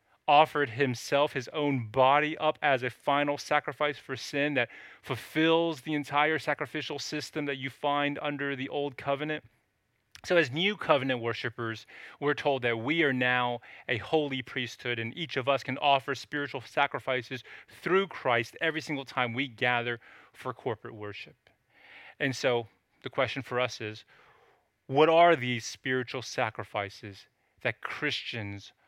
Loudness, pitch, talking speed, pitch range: -29 LUFS, 135 Hz, 150 wpm, 120-150 Hz